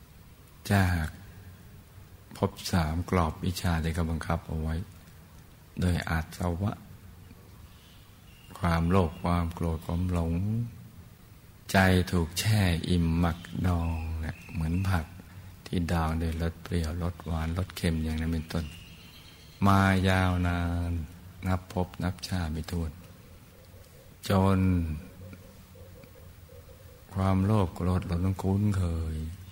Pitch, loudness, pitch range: 90 Hz, -29 LUFS, 85-95 Hz